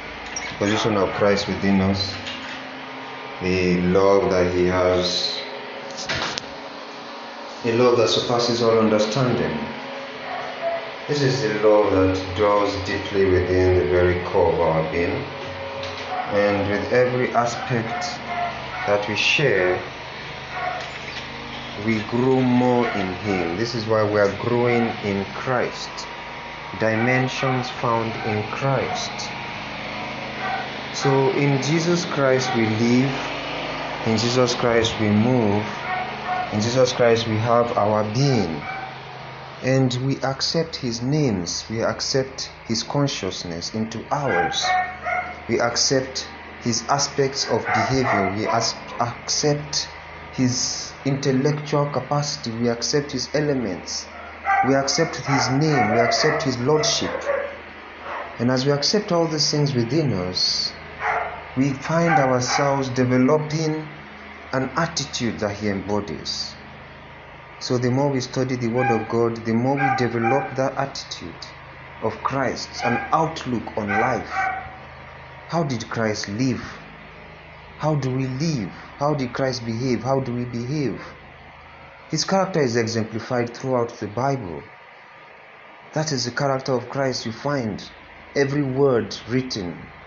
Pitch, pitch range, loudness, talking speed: 120 Hz, 105-135 Hz, -22 LUFS, 120 wpm